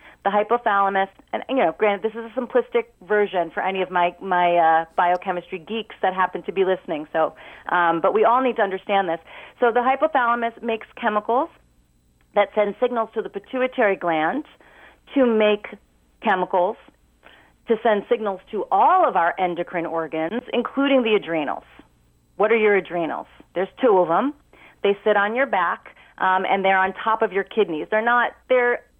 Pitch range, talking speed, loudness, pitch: 180-235 Hz, 175 wpm, -21 LUFS, 200 Hz